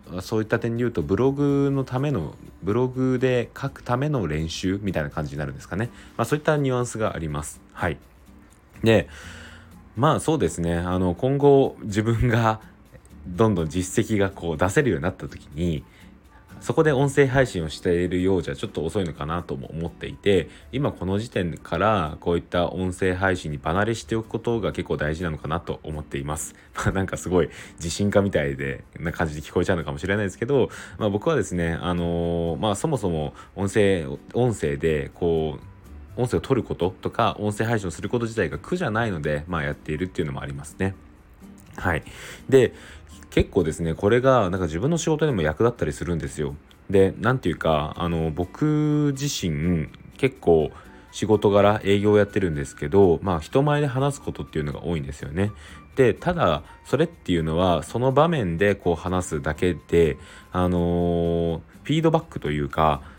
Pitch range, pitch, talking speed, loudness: 80-115 Hz, 90 Hz, 370 characters per minute, -24 LUFS